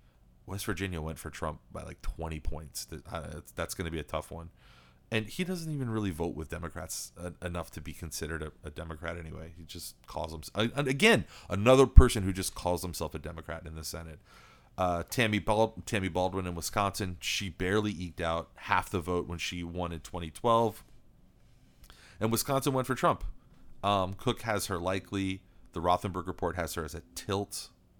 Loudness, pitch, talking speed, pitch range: -32 LUFS, 90 Hz, 175 wpm, 80-105 Hz